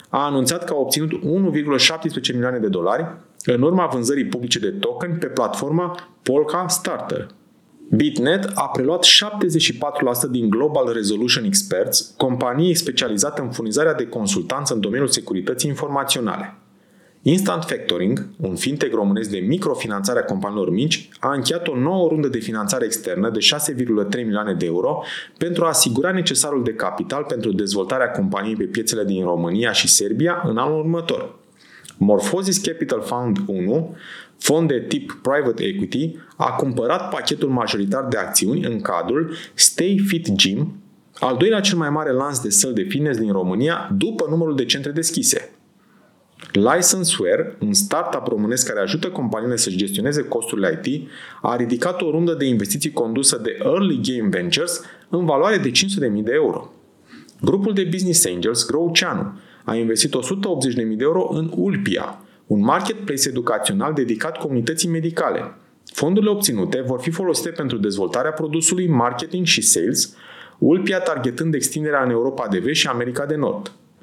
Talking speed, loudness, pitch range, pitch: 150 wpm, -19 LUFS, 125-180 Hz, 155 Hz